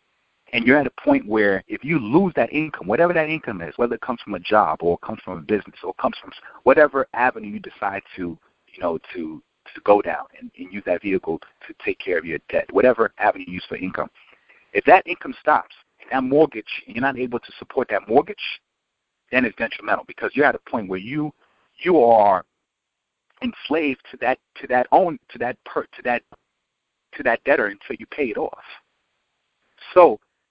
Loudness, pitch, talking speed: -21 LUFS, 150 Hz, 210 wpm